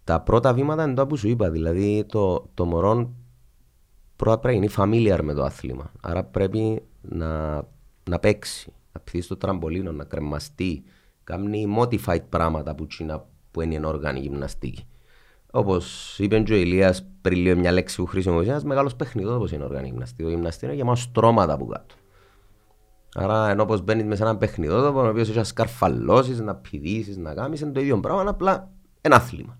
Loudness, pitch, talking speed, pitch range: -23 LUFS, 95 Hz, 175 wpm, 80-110 Hz